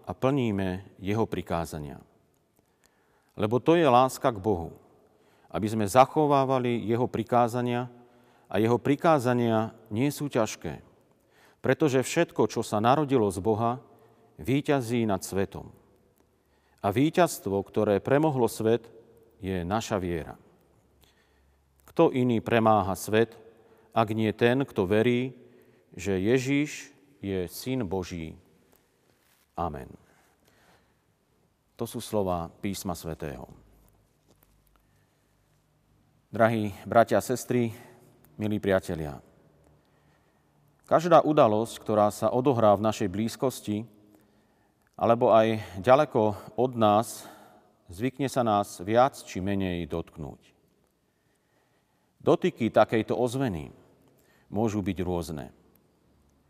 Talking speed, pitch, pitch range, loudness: 95 wpm, 110 Hz, 95-125 Hz, -26 LUFS